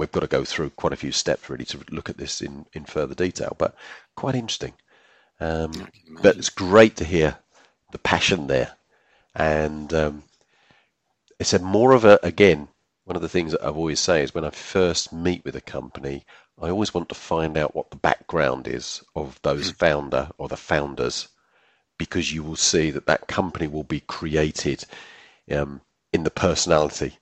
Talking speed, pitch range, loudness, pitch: 185 wpm, 75-90 Hz, -23 LUFS, 80 Hz